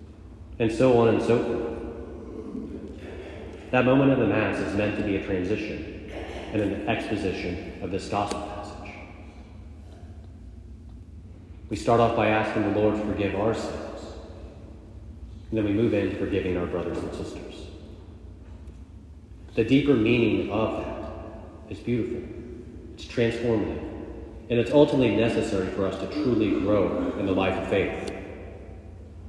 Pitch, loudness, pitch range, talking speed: 100 Hz, -25 LUFS, 85-110 Hz, 140 wpm